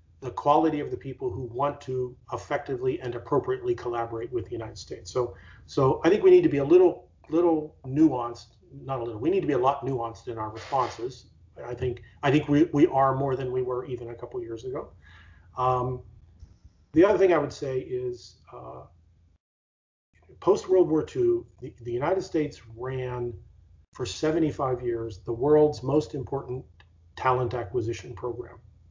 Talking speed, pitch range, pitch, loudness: 180 wpm, 115-150 Hz, 125 Hz, -26 LUFS